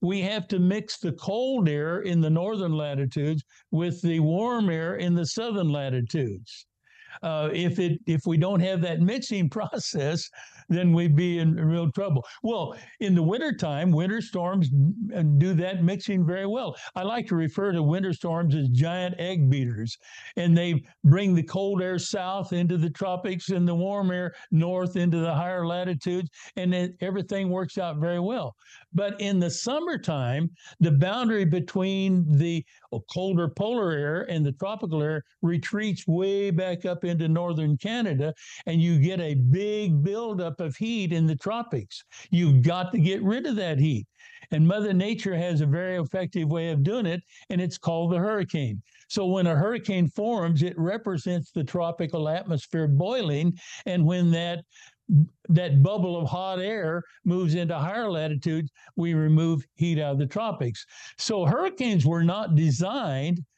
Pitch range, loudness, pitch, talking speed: 160-190 Hz, -26 LUFS, 175 Hz, 165 wpm